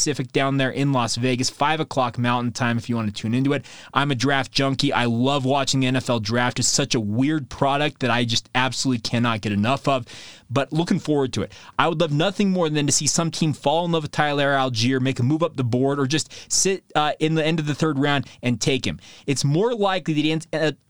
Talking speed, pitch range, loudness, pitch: 250 wpm, 125-150 Hz, -22 LUFS, 135 Hz